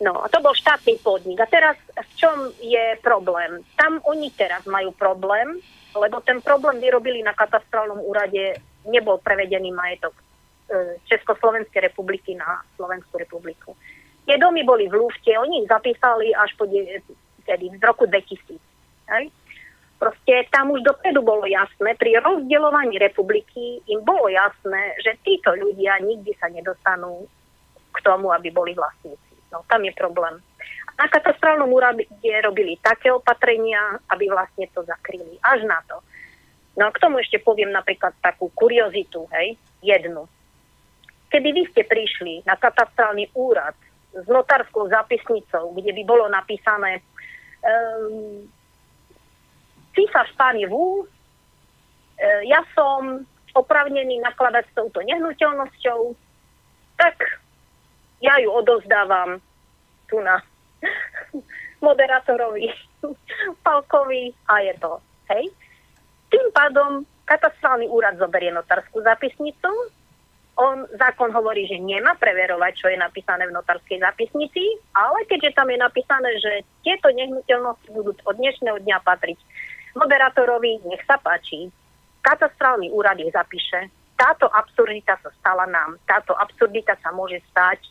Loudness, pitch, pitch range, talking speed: -19 LUFS, 225 Hz, 195-285 Hz, 125 wpm